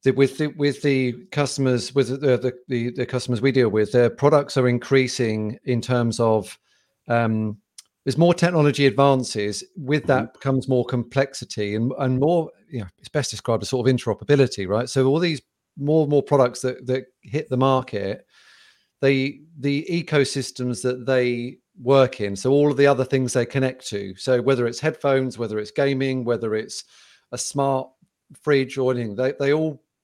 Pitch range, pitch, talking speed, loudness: 120-140 Hz, 130 Hz, 180 wpm, -22 LUFS